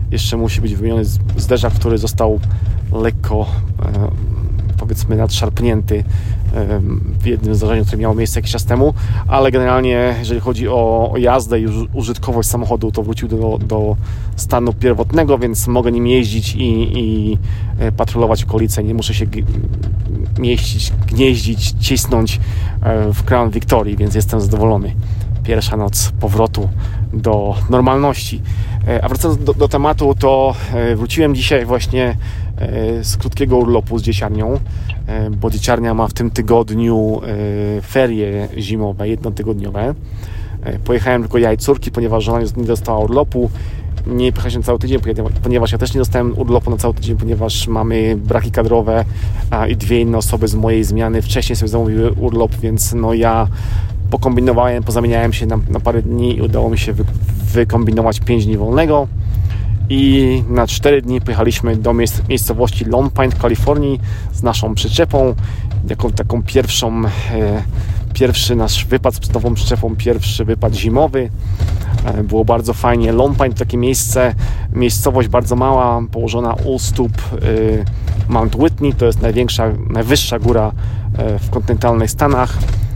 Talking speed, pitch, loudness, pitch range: 145 wpm, 110 Hz, -15 LUFS, 105-120 Hz